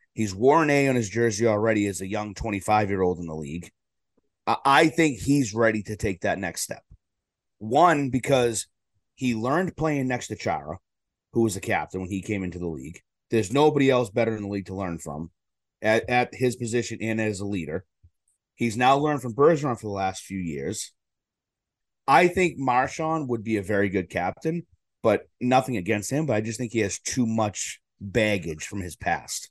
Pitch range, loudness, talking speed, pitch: 95-125 Hz, -25 LUFS, 195 wpm, 110 Hz